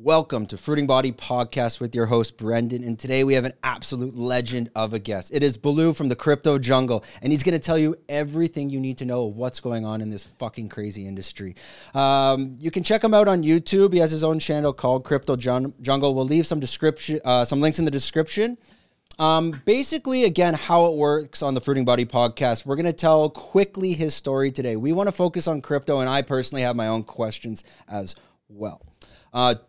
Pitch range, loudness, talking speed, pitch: 120-160 Hz, -22 LUFS, 215 wpm, 135 Hz